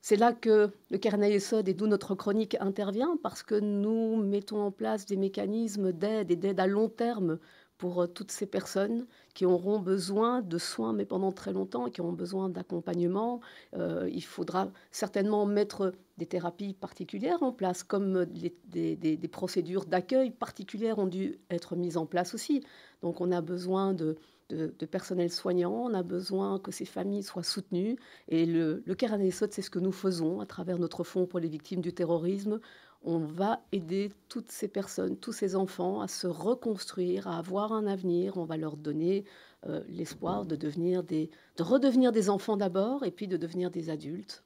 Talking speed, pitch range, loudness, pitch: 190 wpm, 175-210 Hz, -32 LUFS, 190 Hz